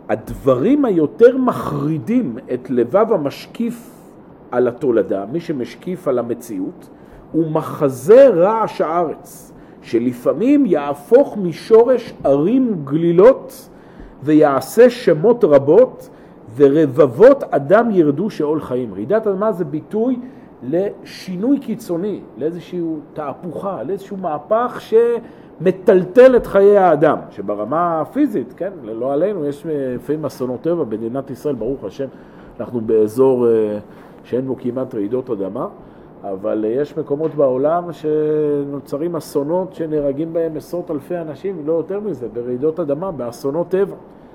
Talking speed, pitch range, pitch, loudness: 110 wpm, 140-210 Hz, 160 Hz, -17 LUFS